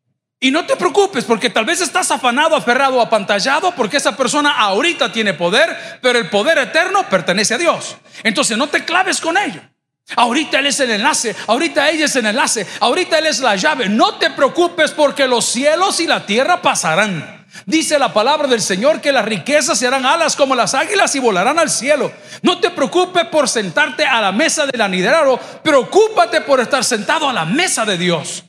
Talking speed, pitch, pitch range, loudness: 190 wpm, 280 Hz, 235-320 Hz, -14 LUFS